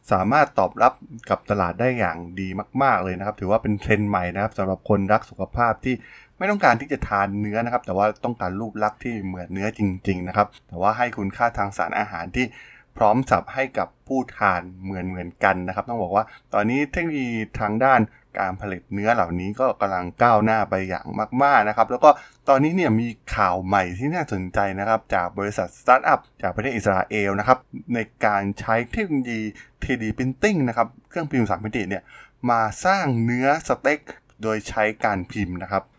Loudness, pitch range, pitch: -22 LUFS, 100-125 Hz, 110 Hz